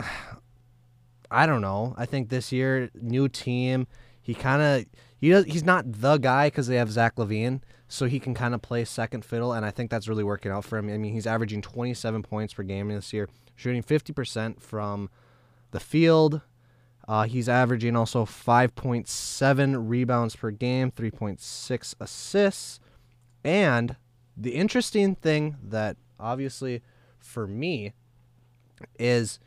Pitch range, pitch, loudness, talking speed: 115-130 Hz, 120 Hz, -26 LUFS, 150 wpm